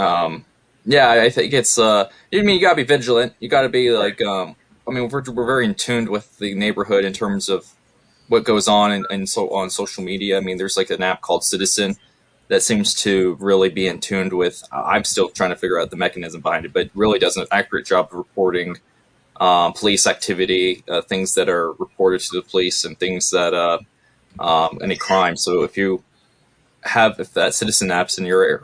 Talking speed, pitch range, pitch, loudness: 215 wpm, 95-125 Hz, 100 Hz, -18 LUFS